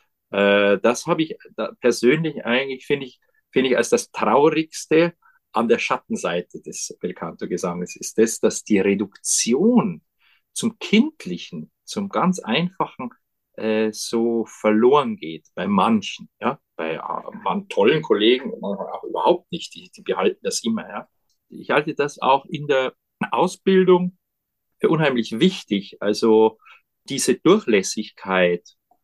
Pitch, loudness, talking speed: 155 Hz, -21 LUFS, 130 wpm